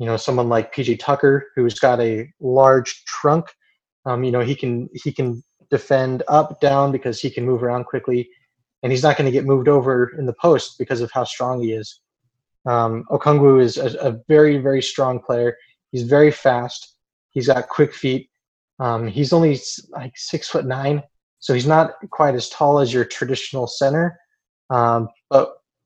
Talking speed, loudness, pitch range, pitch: 185 wpm, -19 LUFS, 120-145 Hz, 130 Hz